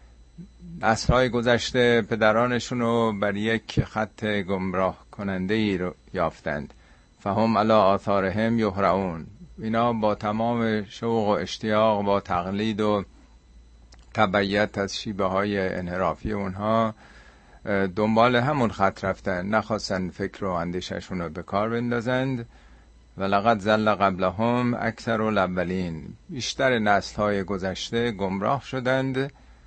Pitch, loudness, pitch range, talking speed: 105 Hz, -24 LUFS, 95-115 Hz, 115 wpm